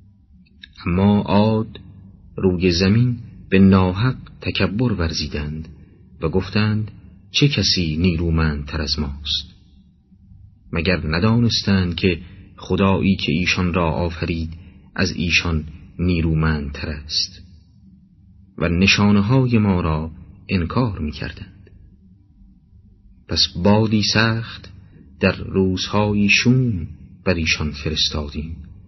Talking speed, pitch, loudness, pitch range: 90 wpm, 95 Hz, -19 LUFS, 85-100 Hz